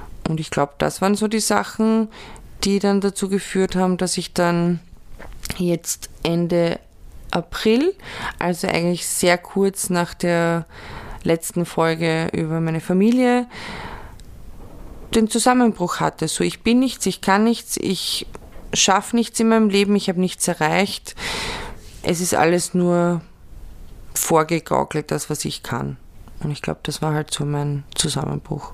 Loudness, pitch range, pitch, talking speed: -20 LUFS, 165-200 Hz, 175 Hz, 140 wpm